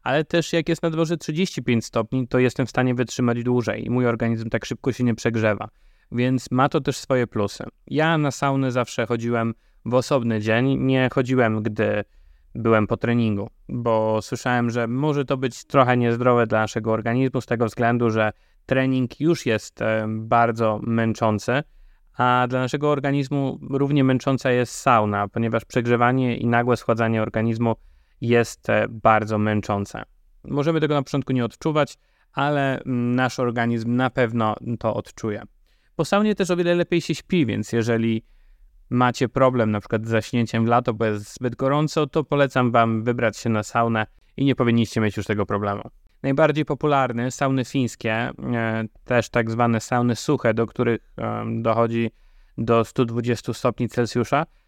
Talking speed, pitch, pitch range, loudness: 160 wpm, 120 Hz, 115-130 Hz, -22 LUFS